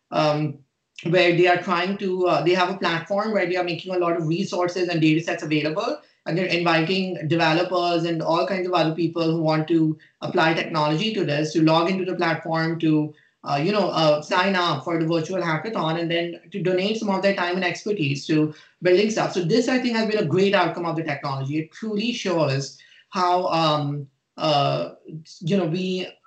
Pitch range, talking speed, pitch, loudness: 160-185 Hz, 205 wpm, 170 Hz, -22 LUFS